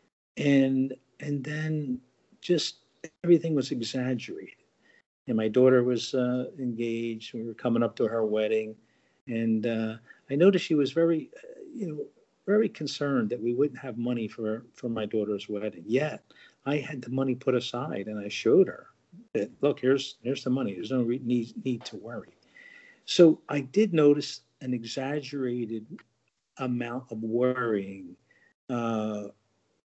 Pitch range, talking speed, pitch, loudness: 115-145 Hz, 155 wpm, 125 Hz, -28 LUFS